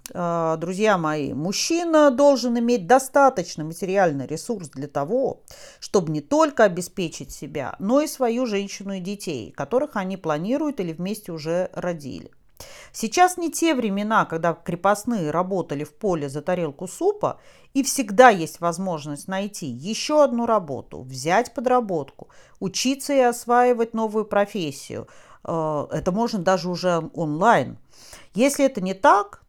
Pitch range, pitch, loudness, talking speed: 165-245 Hz, 195 Hz, -22 LUFS, 130 wpm